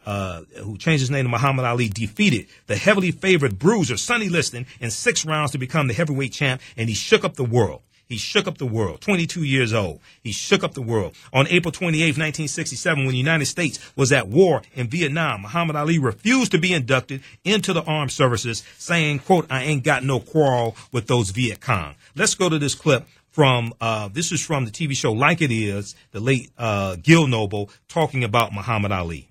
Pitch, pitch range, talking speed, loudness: 135 Hz, 115-165 Hz, 205 wpm, -21 LUFS